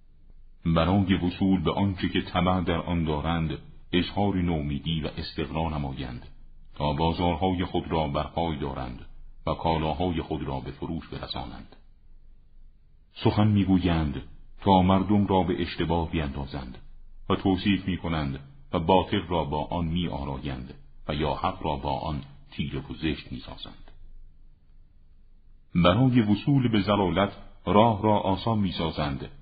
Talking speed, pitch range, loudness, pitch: 130 wpm, 75-95 Hz, -27 LUFS, 85 Hz